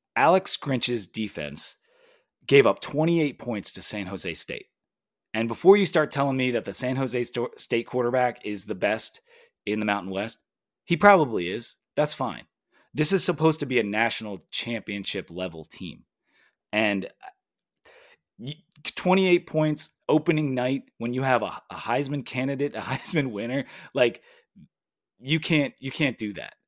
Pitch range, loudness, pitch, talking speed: 115-160 Hz, -25 LUFS, 130 Hz, 150 wpm